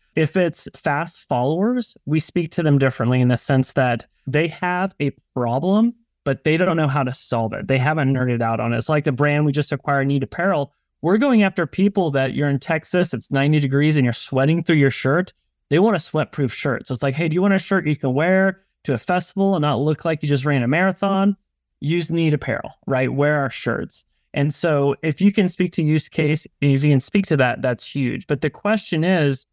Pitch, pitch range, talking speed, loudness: 150 Hz, 135-180 Hz, 235 wpm, -20 LUFS